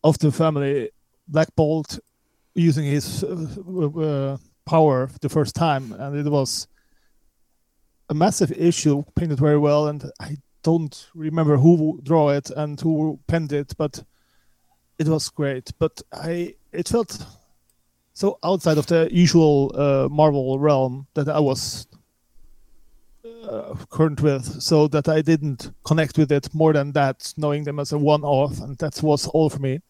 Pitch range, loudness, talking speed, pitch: 140-160 Hz, -21 LUFS, 155 wpm, 150 Hz